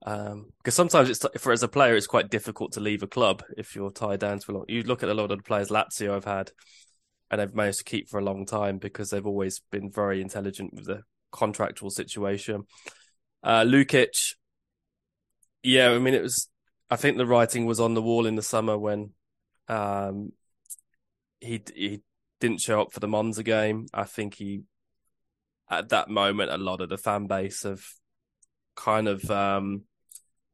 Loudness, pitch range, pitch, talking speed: -26 LUFS, 100-110 Hz, 105 Hz, 190 wpm